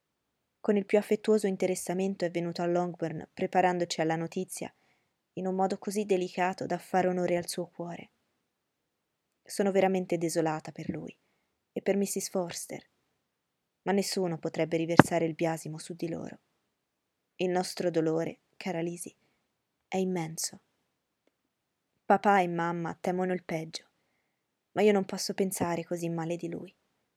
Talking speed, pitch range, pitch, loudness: 140 wpm, 170-190 Hz, 180 Hz, -30 LUFS